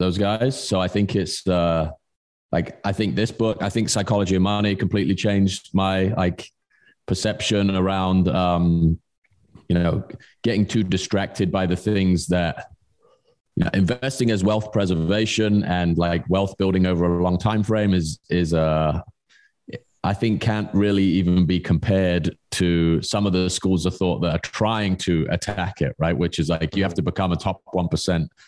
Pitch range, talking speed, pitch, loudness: 90-105 Hz, 175 wpm, 95 Hz, -22 LUFS